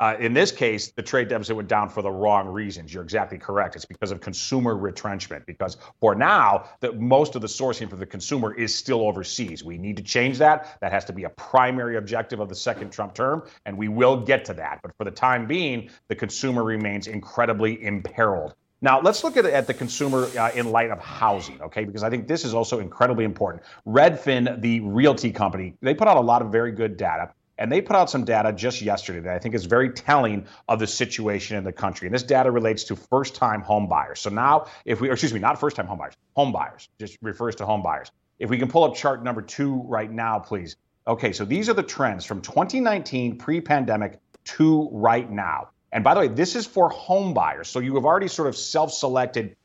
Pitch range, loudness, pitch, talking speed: 105-130 Hz, -23 LUFS, 115 Hz, 230 wpm